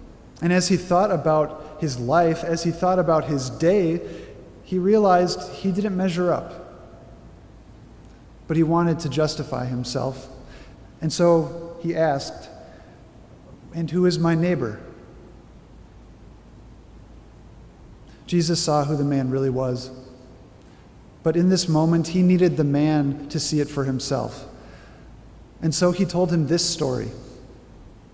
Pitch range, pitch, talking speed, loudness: 130-170 Hz, 155 Hz, 130 wpm, -22 LUFS